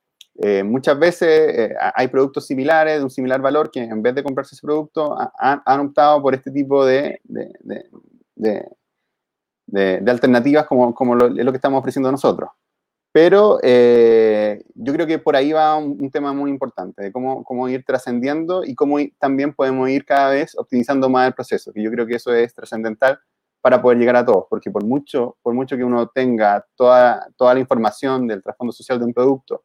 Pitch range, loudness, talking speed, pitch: 120-145 Hz, -17 LUFS, 200 wpm, 130 Hz